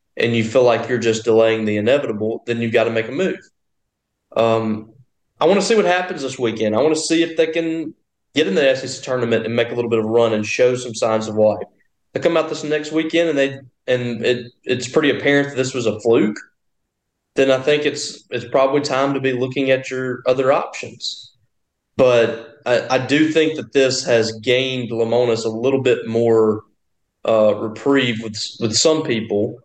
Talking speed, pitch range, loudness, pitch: 210 wpm, 115-135 Hz, -18 LUFS, 125 Hz